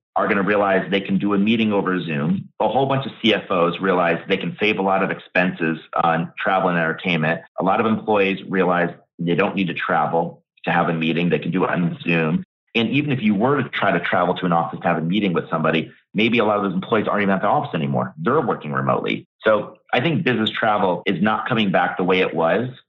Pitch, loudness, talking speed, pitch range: 90 Hz, -20 LUFS, 245 wpm, 85-105 Hz